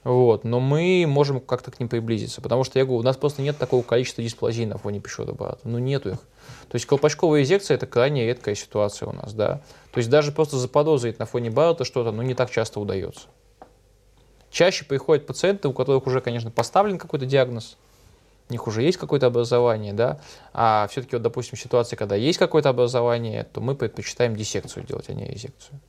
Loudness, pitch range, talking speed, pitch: -23 LUFS, 115-140 Hz, 195 wpm, 125 Hz